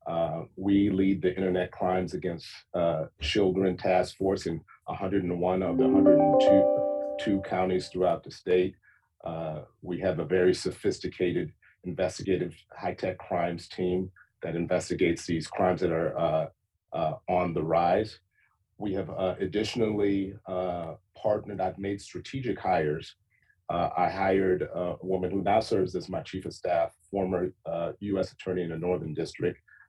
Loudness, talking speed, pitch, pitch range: -28 LUFS, 150 wpm, 95 Hz, 90-100 Hz